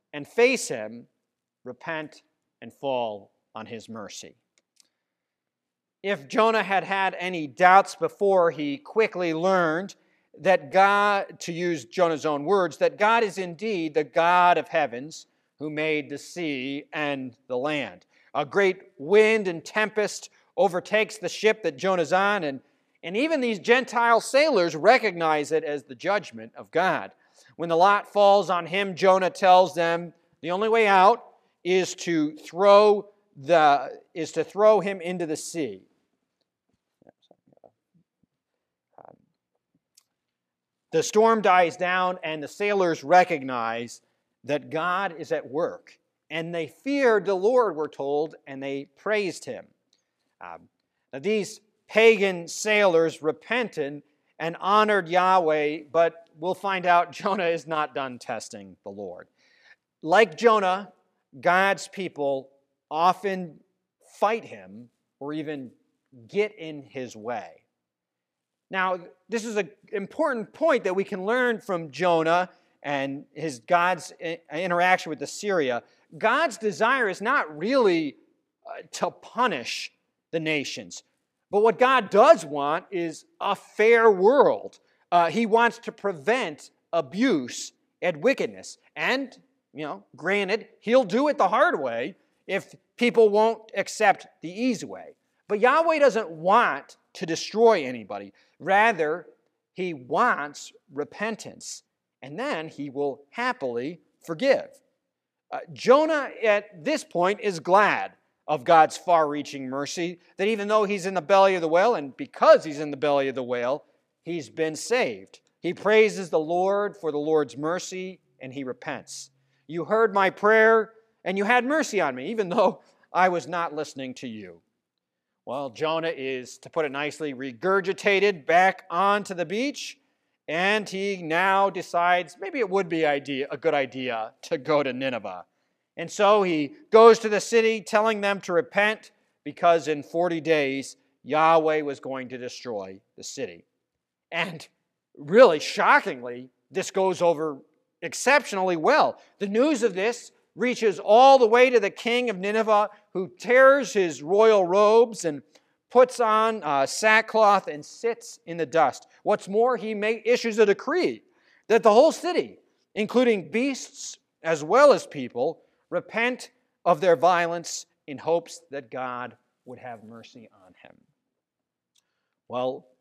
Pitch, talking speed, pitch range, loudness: 180 Hz, 140 wpm, 155-215 Hz, -23 LUFS